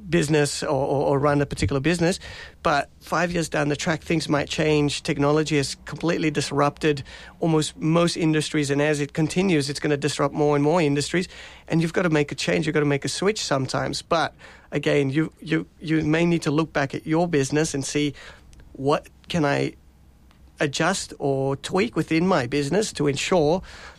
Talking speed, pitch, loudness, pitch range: 190 wpm, 150 Hz, -23 LUFS, 145-160 Hz